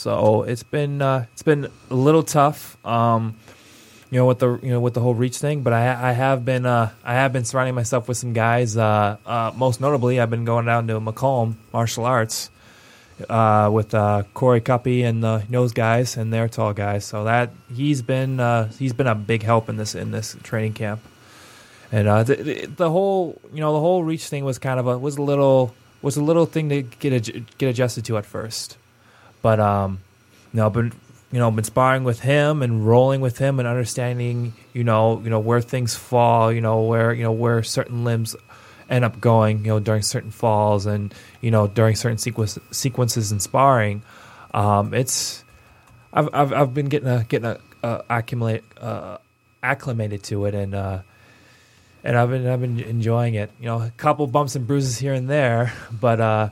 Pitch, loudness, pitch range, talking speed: 120 Hz, -21 LUFS, 110-130 Hz, 205 wpm